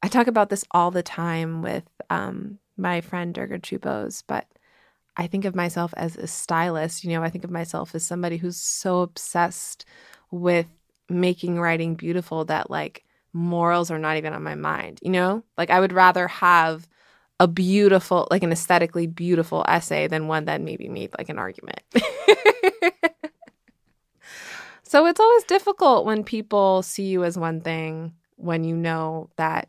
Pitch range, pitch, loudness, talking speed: 165-190 Hz, 175 Hz, -22 LUFS, 165 wpm